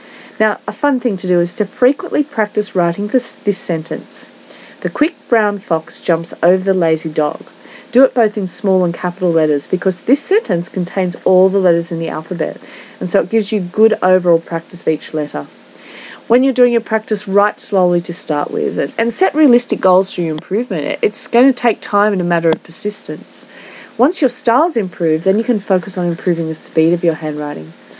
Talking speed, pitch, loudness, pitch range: 200 wpm, 190 Hz, -15 LUFS, 170-230 Hz